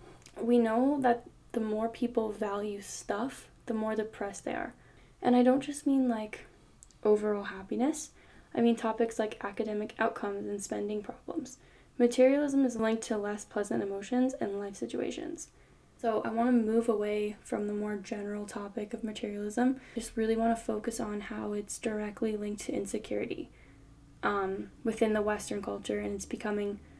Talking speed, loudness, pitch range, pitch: 160 wpm, -32 LUFS, 210-235 Hz, 220 Hz